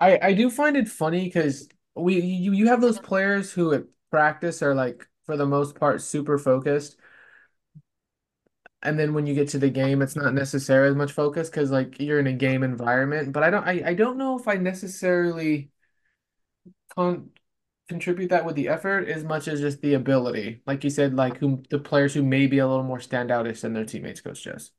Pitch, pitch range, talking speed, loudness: 145 Hz, 135-175 Hz, 210 wpm, -24 LUFS